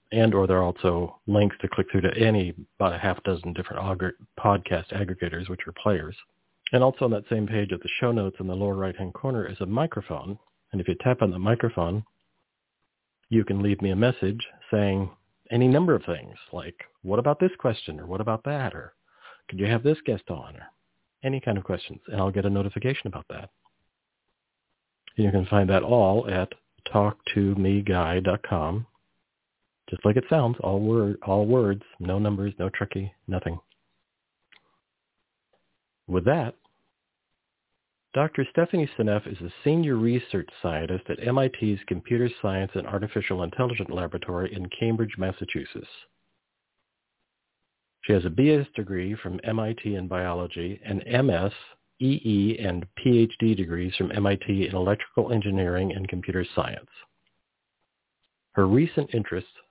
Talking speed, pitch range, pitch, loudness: 155 wpm, 95-115 Hz, 100 Hz, -26 LUFS